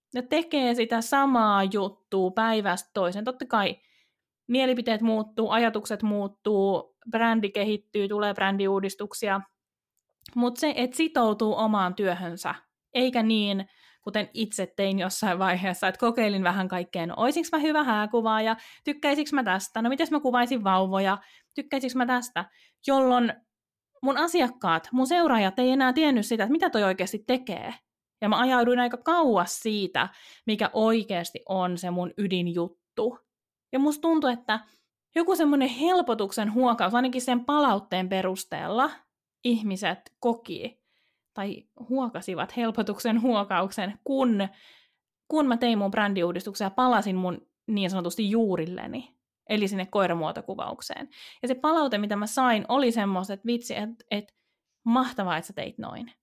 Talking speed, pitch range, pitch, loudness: 135 wpm, 195-255 Hz, 220 Hz, -26 LUFS